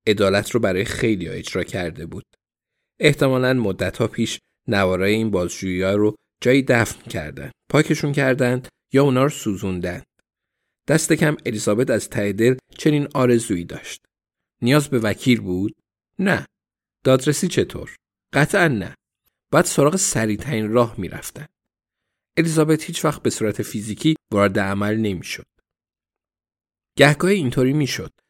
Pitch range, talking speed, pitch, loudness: 105-145 Hz, 135 wpm, 120 Hz, -20 LUFS